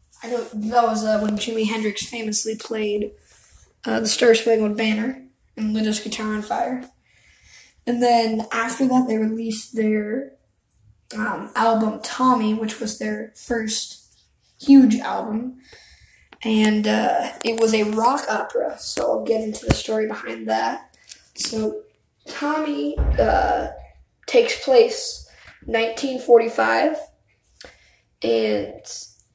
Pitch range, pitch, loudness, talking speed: 215-250 Hz, 225 Hz, -21 LUFS, 125 wpm